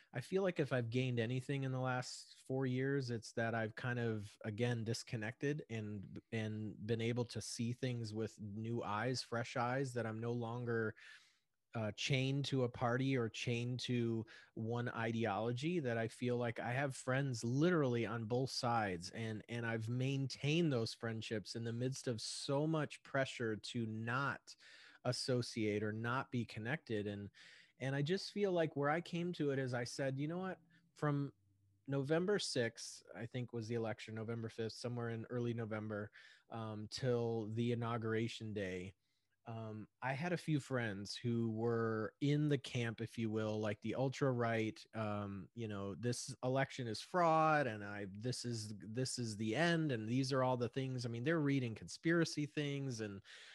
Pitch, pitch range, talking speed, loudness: 120 Hz, 110-135 Hz, 175 wpm, -40 LUFS